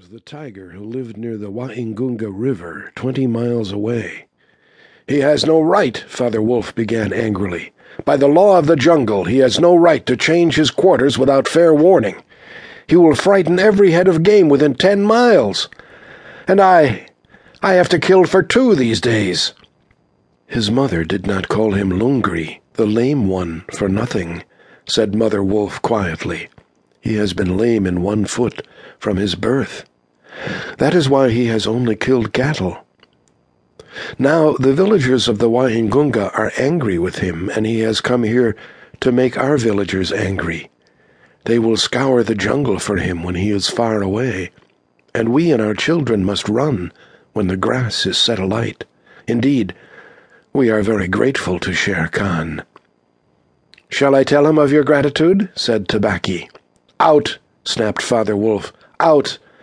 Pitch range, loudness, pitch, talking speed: 105-145 Hz, -15 LUFS, 120 Hz, 160 wpm